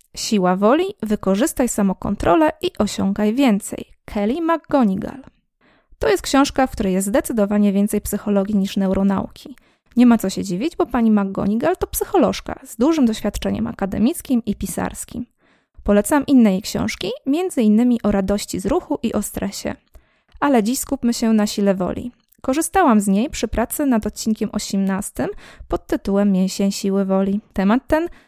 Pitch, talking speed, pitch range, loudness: 220 Hz, 150 wpm, 200-270 Hz, -19 LUFS